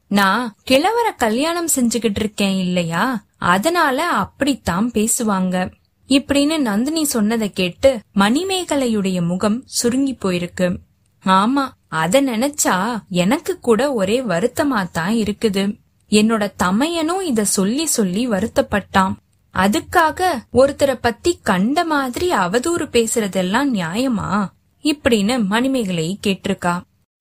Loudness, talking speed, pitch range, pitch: -18 LUFS, 95 wpm, 195-275 Hz, 230 Hz